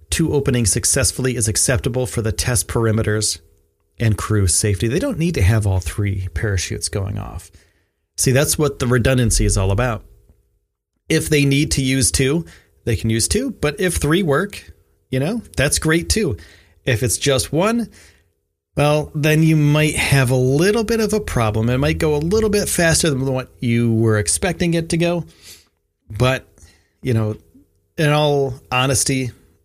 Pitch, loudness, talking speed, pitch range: 115 Hz, -18 LUFS, 170 wpm, 95-145 Hz